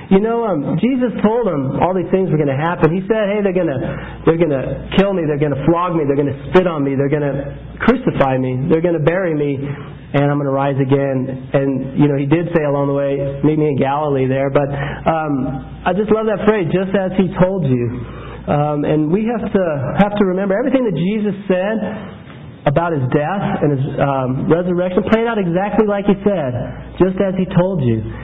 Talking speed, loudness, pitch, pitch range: 225 wpm, -16 LUFS, 160 Hz, 140-195 Hz